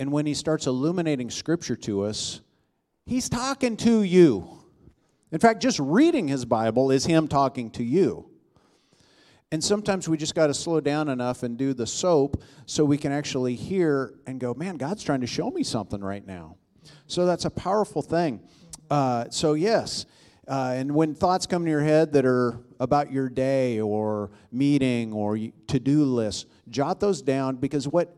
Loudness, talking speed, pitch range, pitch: -25 LUFS, 180 wpm, 125-160 Hz, 140 Hz